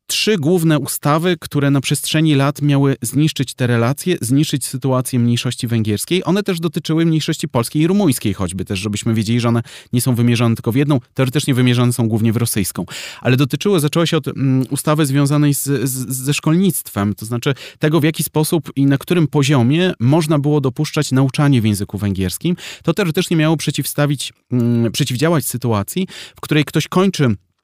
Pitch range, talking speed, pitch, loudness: 120-155 Hz, 170 wpm, 140 Hz, -17 LUFS